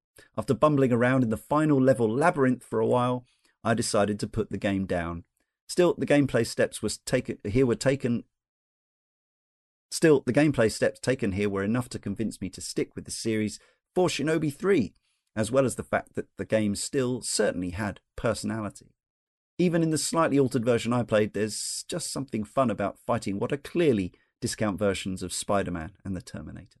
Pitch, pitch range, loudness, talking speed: 110 Hz, 100-135 Hz, -27 LUFS, 185 wpm